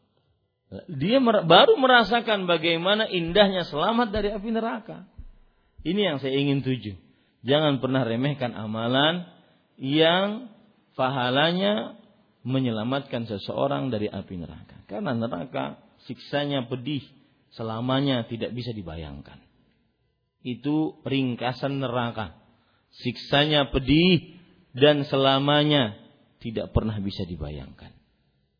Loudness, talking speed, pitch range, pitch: -24 LUFS, 90 wpm, 115-165 Hz, 135 Hz